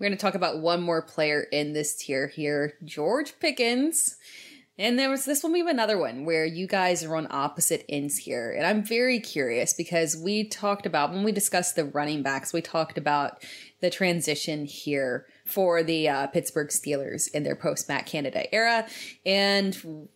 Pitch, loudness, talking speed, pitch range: 170 Hz, -26 LUFS, 185 wpm, 150-210 Hz